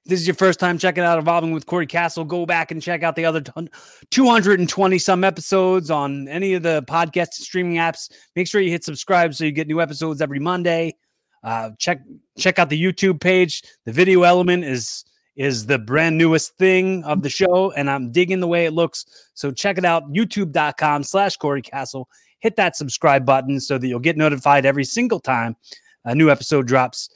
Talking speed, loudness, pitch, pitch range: 205 wpm, -19 LUFS, 165 Hz, 145-180 Hz